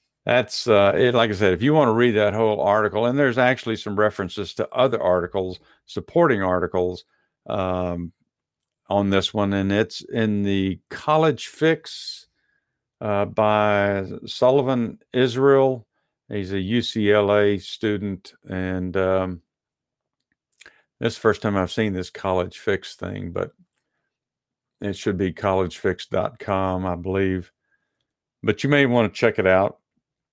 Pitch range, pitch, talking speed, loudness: 95-115 Hz, 100 Hz, 140 wpm, -22 LUFS